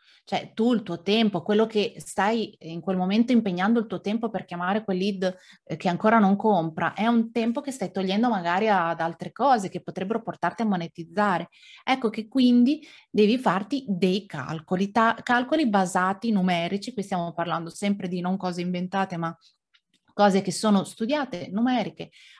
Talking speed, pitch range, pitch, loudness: 170 wpm, 180-230 Hz, 200 Hz, -25 LUFS